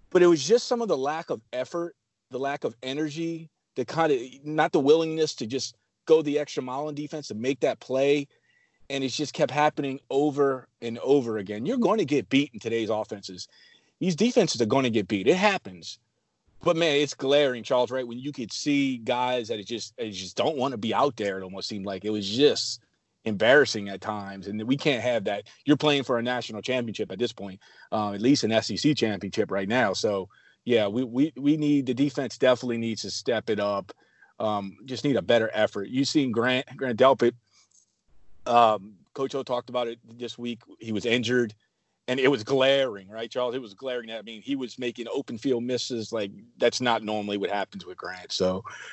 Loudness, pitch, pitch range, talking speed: -26 LUFS, 125 Hz, 110-140 Hz, 215 wpm